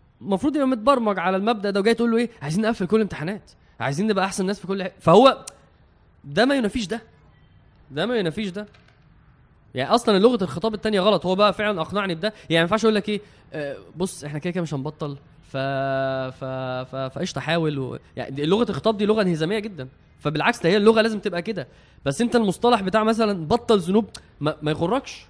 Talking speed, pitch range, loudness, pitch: 200 wpm, 150-220 Hz, -22 LUFS, 195 Hz